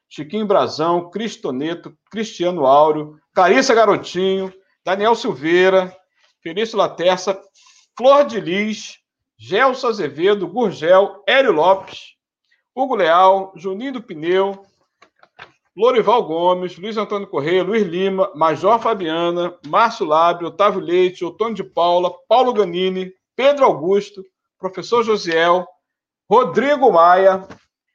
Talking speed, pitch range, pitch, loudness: 105 wpm, 180-220 Hz, 190 Hz, -17 LUFS